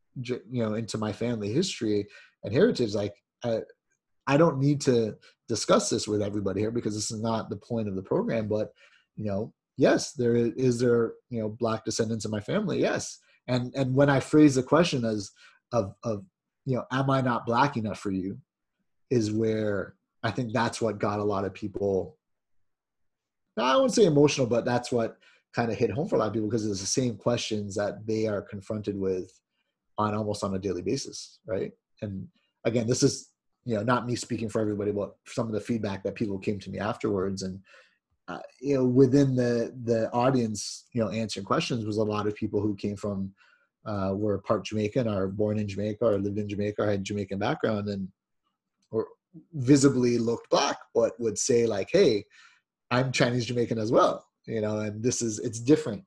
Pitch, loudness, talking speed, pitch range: 110 Hz, -27 LUFS, 200 wpm, 105-125 Hz